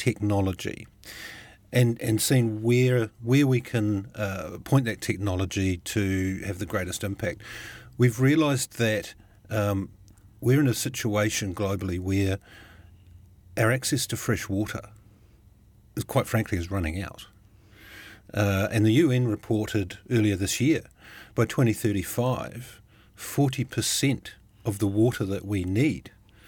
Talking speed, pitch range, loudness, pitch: 125 wpm, 100-120 Hz, -26 LUFS, 105 Hz